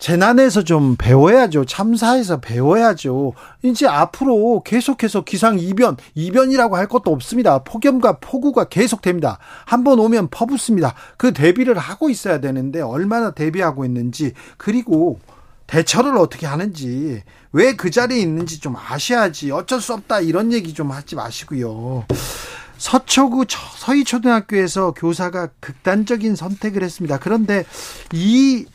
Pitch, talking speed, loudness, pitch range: 195 Hz, 320 characters per minute, -17 LUFS, 155-240 Hz